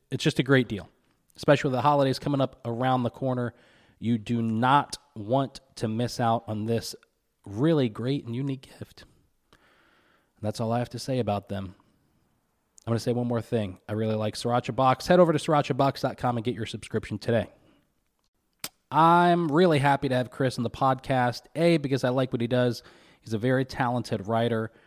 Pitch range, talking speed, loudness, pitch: 115-135 Hz, 190 wpm, -26 LUFS, 125 Hz